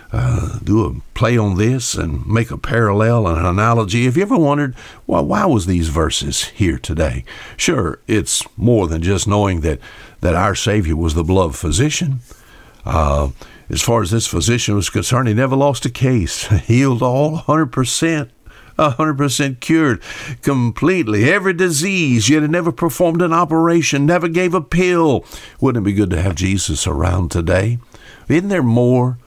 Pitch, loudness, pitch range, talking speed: 115 Hz, -16 LUFS, 100-145 Hz, 175 wpm